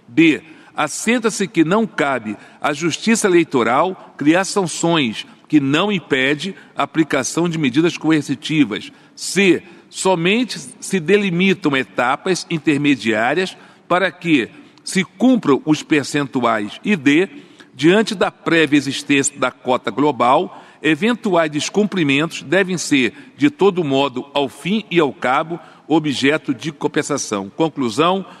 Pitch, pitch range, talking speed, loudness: 160 Hz, 145-190 Hz, 115 wpm, -17 LUFS